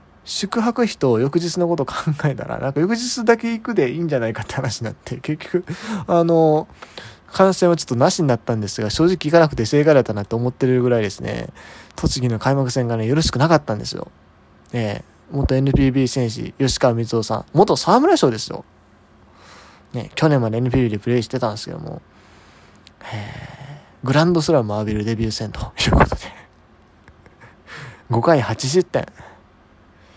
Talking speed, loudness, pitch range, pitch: 340 characters per minute, -19 LUFS, 110-160 Hz, 130 Hz